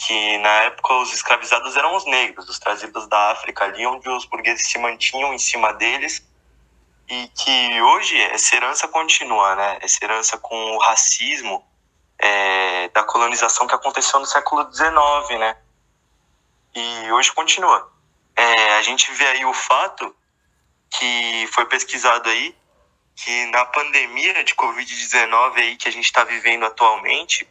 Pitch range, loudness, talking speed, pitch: 100-125 Hz, -17 LUFS, 150 wpm, 115 Hz